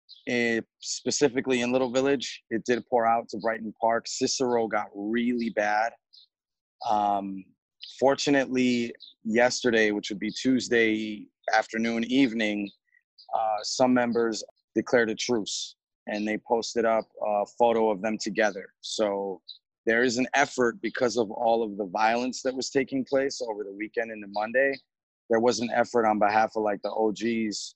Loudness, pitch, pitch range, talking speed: -26 LUFS, 115 Hz, 110-125 Hz, 155 wpm